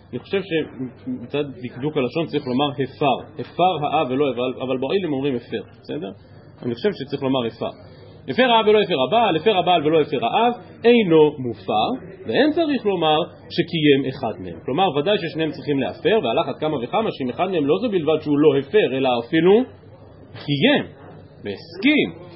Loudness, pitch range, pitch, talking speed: -20 LUFS, 130-180 Hz, 145 Hz, 165 wpm